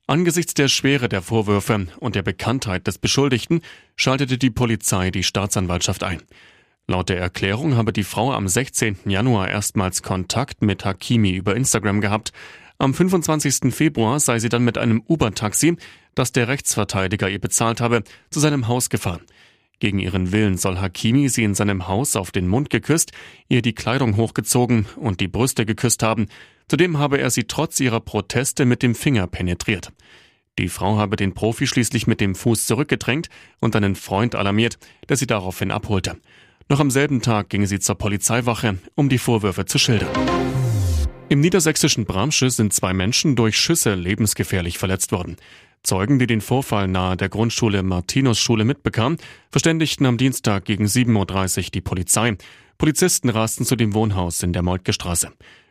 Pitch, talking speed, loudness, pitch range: 110 Hz, 165 wpm, -20 LUFS, 100-130 Hz